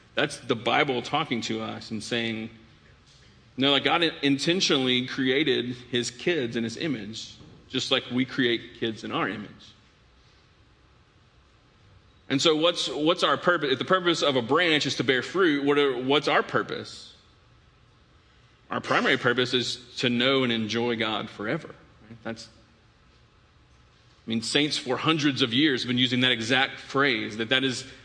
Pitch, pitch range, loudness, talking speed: 125 Hz, 115-140 Hz, -25 LUFS, 165 wpm